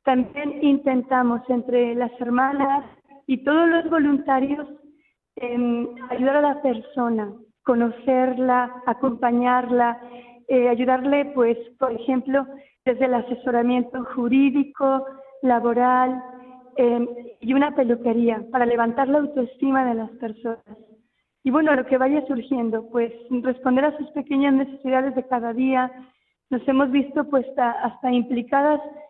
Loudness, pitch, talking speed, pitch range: -22 LUFS, 255 Hz, 120 wpm, 240-275 Hz